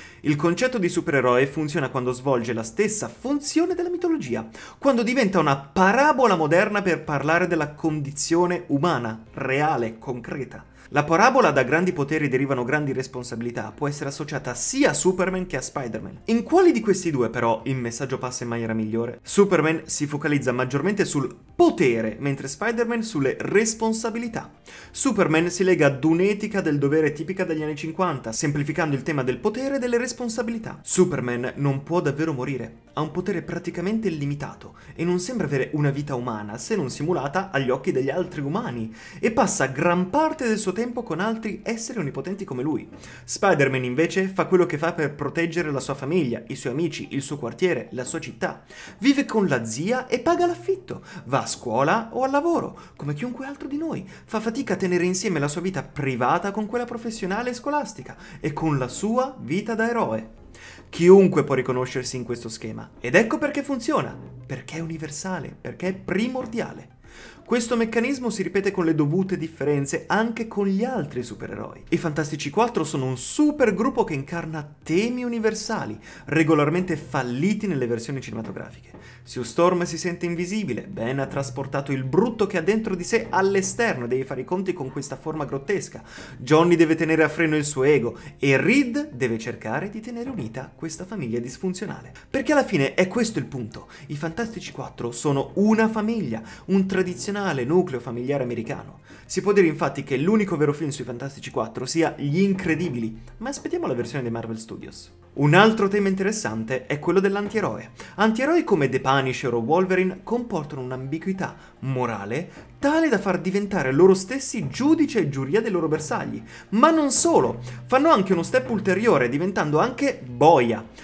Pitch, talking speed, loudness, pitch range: 165 Hz, 170 wpm, -23 LUFS, 135-205 Hz